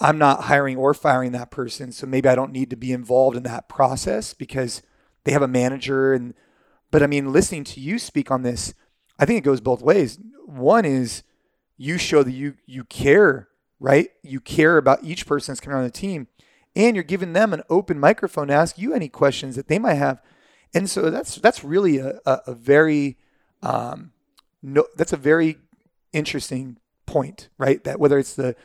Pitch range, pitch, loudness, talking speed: 130-155 Hz, 140 Hz, -20 LUFS, 200 wpm